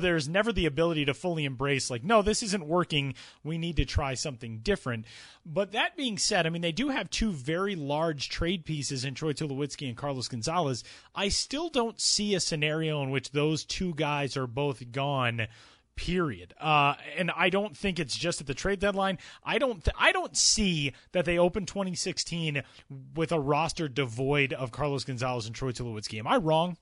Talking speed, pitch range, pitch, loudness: 195 wpm, 135-180 Hz, 155 Hz, -29 LUFS